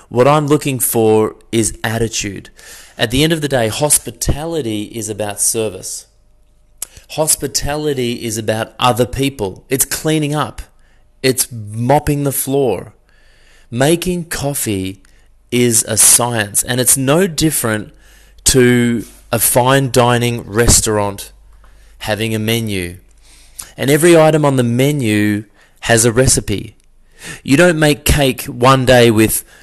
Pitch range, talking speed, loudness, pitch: 110-140 Hz, 125 wpm, -14 LUFS, 120 Hz